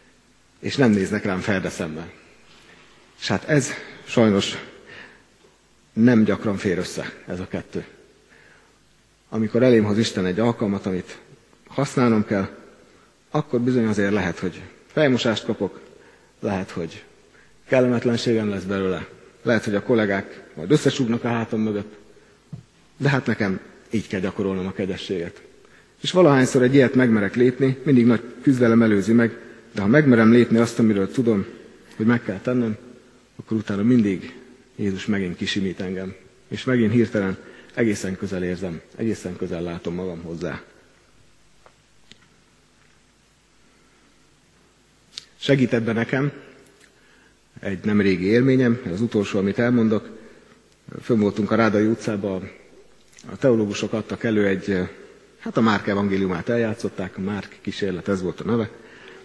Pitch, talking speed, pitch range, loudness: 110 Hz, 130 wpm, 100-120 Hz, -22 LUFS